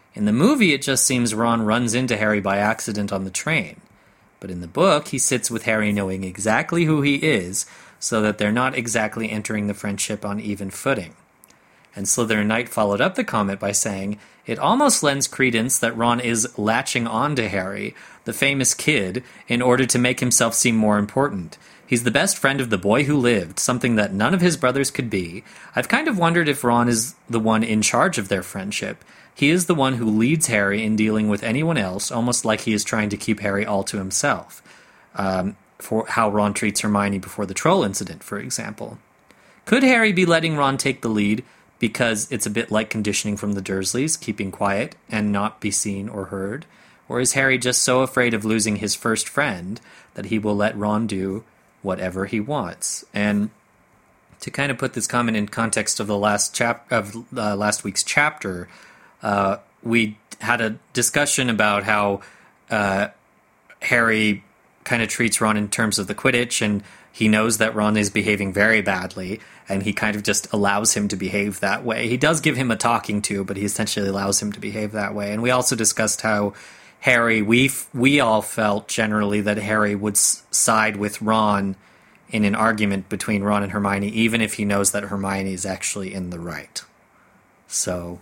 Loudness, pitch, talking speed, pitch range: -20 LUFS, 110 Hz, 200 wpm, 100-120 Hz